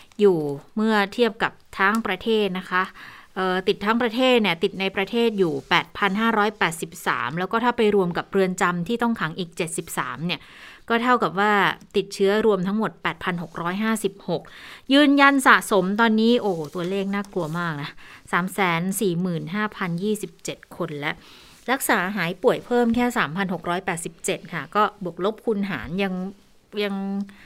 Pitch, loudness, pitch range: 195 Hz, -22 LUFS, 180-215 Hz